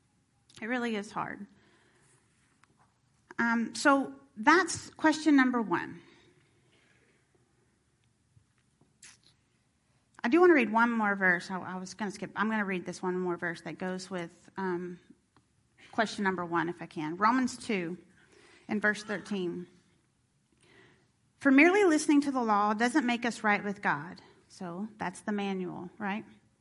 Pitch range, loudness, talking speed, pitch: 180-240 Hz, -29 LUFS, 145 wpm, 205 Hz